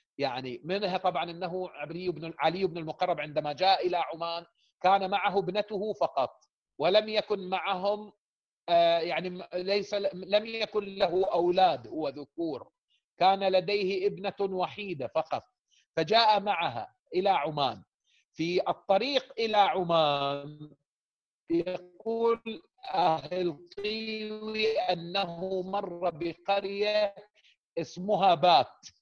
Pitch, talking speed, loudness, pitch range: 190 Hz, 95 wpm, -29 LUFS, 175-210 Hz